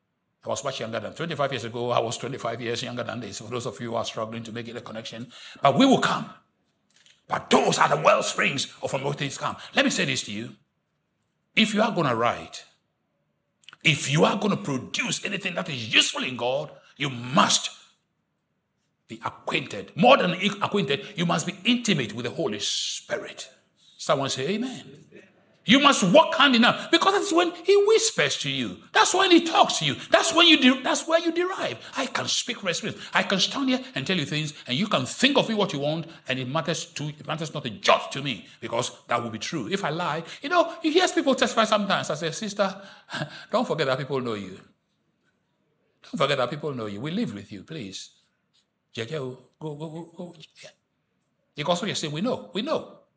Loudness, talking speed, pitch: -24 LUFS, 210 wpm, 165 Hz